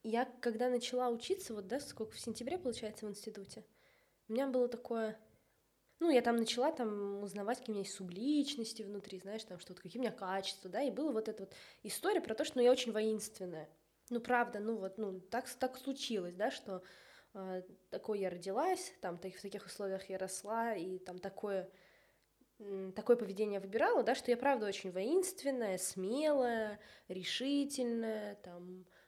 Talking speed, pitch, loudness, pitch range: 175 wpm, 220 Hz, -38 LUFS, 195-245 Hz